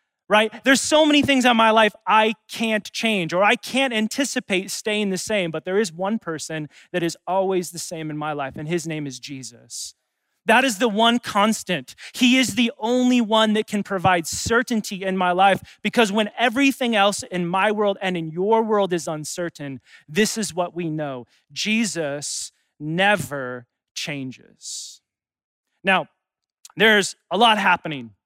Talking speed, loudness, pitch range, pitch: 170 wpm, -20 LUFS, 160-225 Hz, 195 Hz